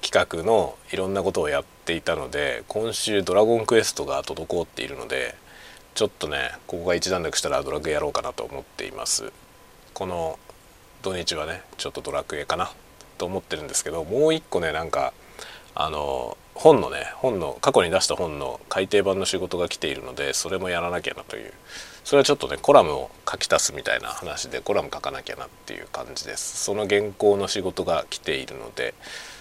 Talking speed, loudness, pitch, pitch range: 390 characters per minute, -24 LUFS, 105 Hz, 100-115 Hz